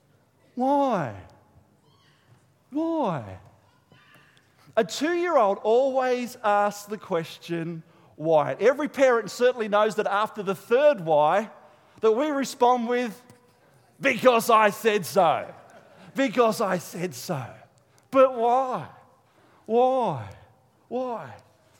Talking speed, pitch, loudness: 95 wpm, 205 Hz, -24 LUFS